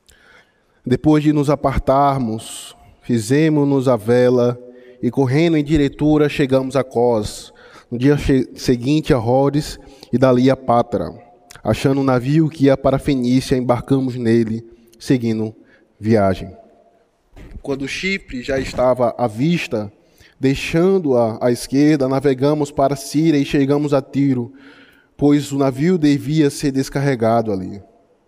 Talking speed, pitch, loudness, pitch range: 125 wpm, 135 Hz, -17 LUFS, 120-145 Hz